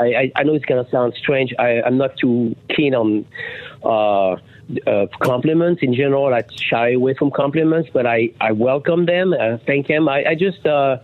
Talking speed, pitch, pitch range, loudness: 190 wpm, 130 Hz, 120-150 Hz, -17 LUFS